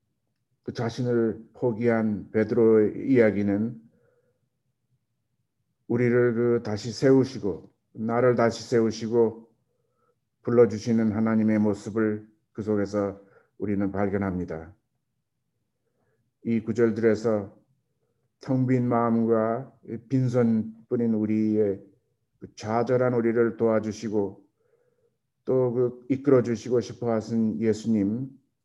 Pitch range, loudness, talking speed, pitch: 110-125 Hz, -25 LUFS, 215 characters per minute, 115 Hz